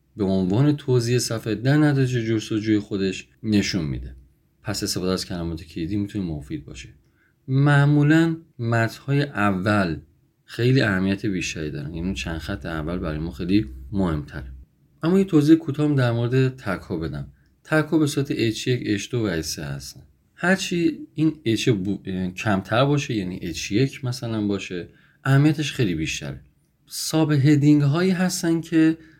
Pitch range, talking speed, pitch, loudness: 95-145 Hz, 140 wpm, 115 Hz, -22 LUFS